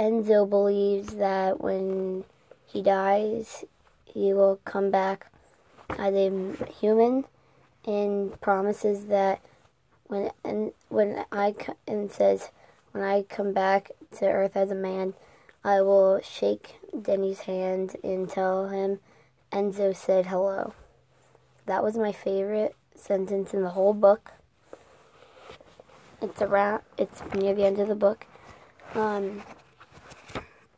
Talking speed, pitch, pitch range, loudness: 120 wpm, 195 Hz, 195-205 Hz, -26 LUFS